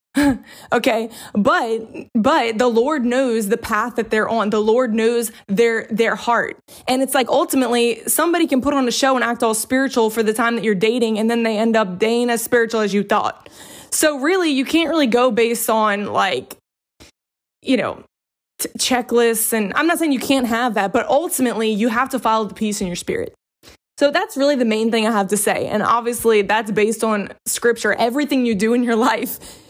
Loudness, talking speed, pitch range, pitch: -18 LUFS, 205 wpm, 220-265 Hz, 235 Hz